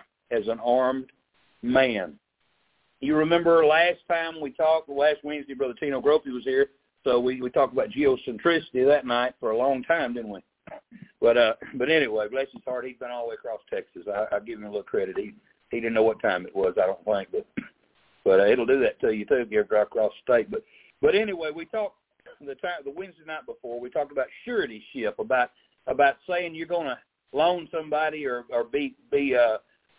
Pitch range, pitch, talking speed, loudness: 130-195 Hz, 155 Hz, 215 wpm, -25 LUFS